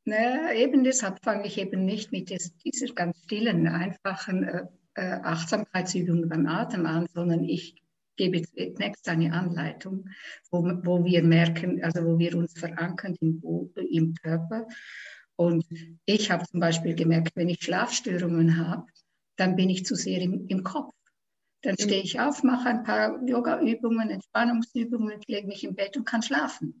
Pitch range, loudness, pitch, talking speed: 170-220 Hz, -27 LUFS, 185 Hz, 155 wpm